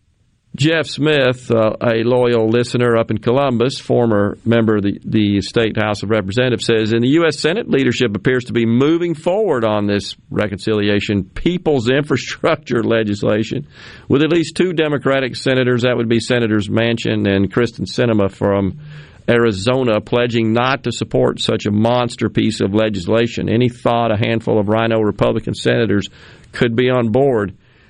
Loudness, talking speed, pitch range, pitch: -16 LUFS, 155 wpm, 110-125 Hz, 115 Hz